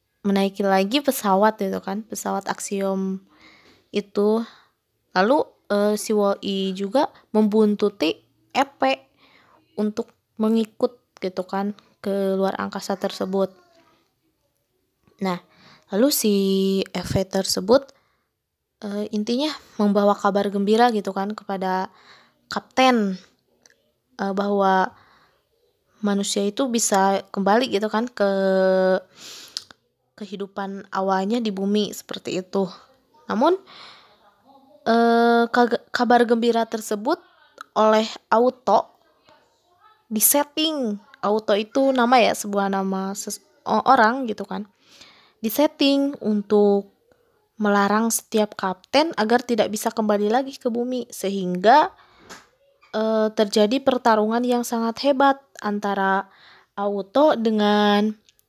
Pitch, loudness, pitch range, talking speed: 210 Hz, -21 LUFS, 200-245 Hz, 95 wpm